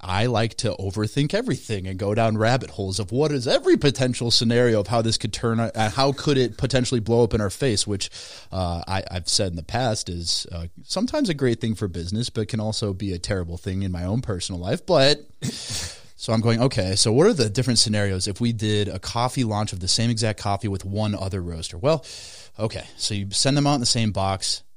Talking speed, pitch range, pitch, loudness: 235 wpm, 95-120 Hz, 110 Hz, -23 LUFS